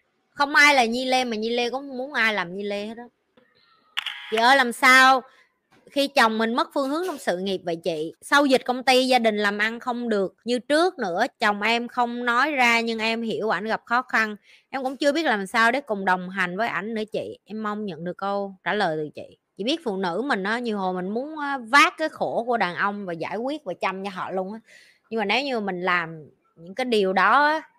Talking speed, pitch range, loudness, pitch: 250 wpm, 200-260 Hz, -22 LUFS, 225 Hz